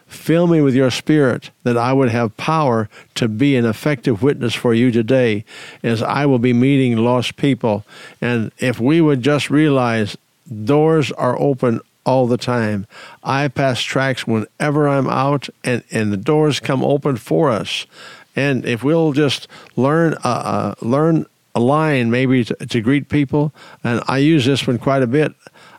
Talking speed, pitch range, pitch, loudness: 170 wpm, 120-145 Hz, 130 Hz, -17 LUFS